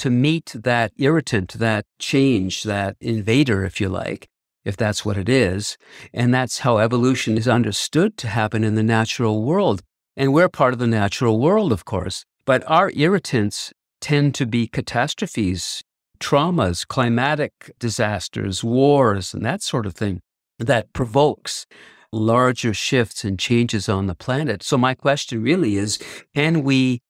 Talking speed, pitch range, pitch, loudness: 155 wpm, 105-135 Hz, 115 Hz, -20 LUFS